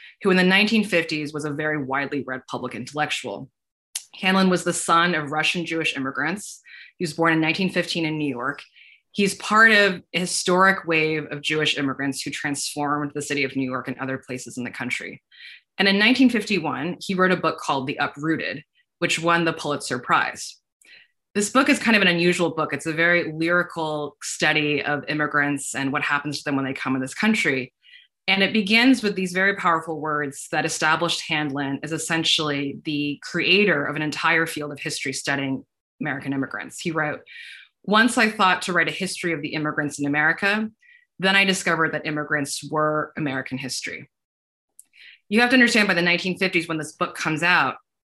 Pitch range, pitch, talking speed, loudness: 145-185 Hz, 160 Hz, 185 wpm, -22 LUFS